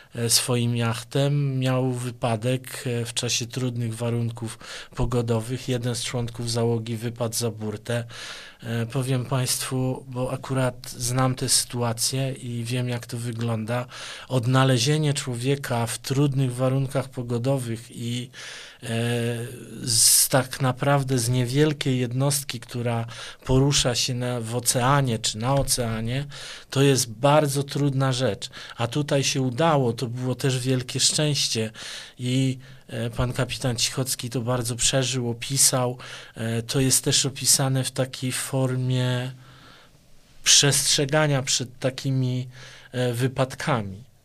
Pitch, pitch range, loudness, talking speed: 130 Hz, 120-135 Hz, -23 LUFS, 120 wpm